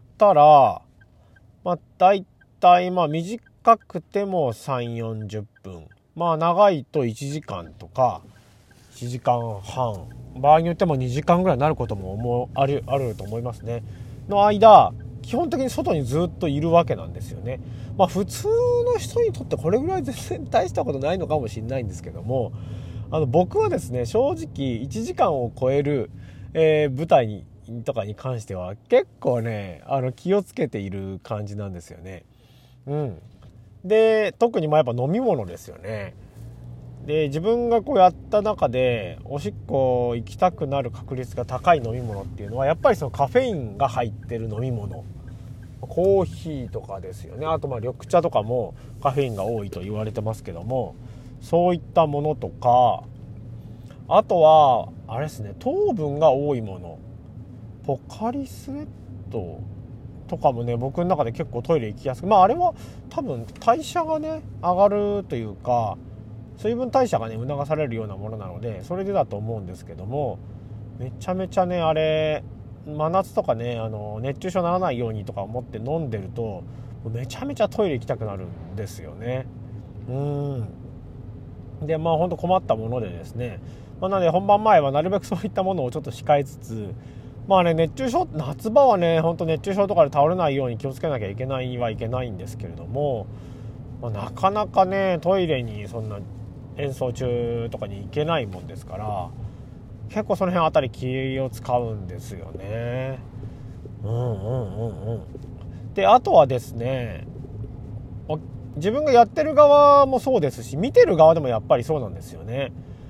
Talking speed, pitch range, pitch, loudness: 315 characters per minute, 110-160 Hz, 125 Hz, -22 LUFS